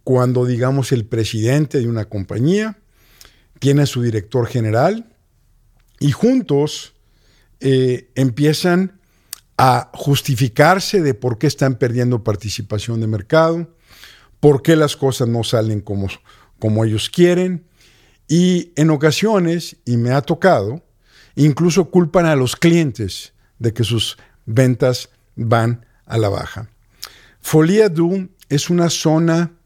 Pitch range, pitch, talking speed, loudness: 115-160 Hz, 130 Hz, 120 wpm, -17 LUFS